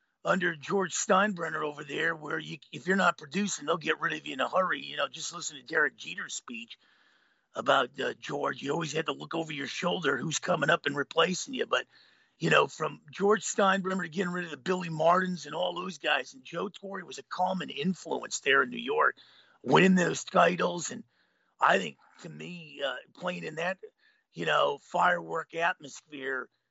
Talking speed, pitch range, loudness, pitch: 200 wpm, 165-195 Hz, -29 LUFS, 180 Hz